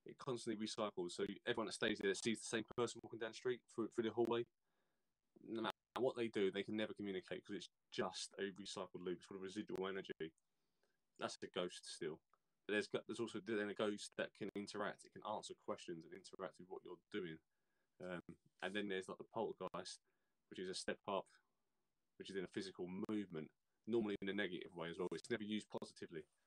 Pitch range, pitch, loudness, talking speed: 95-115 Hz, 105 Hz, -46 LUFS, 205 wpm